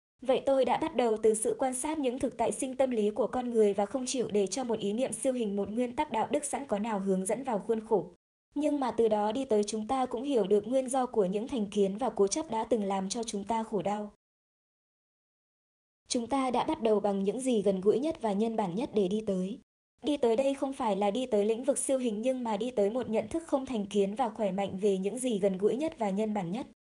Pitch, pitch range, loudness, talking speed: 225 Hz, 205-260 Hz, -30 LUFS, 270 wpm